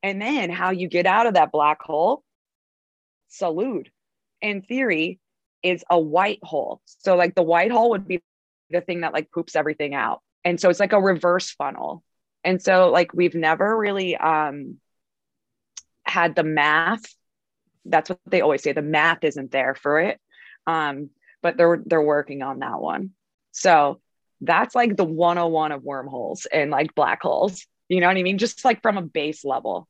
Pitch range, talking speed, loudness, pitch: 155-190 Hz, 180 wpm, -21 LUFS, 175 Hz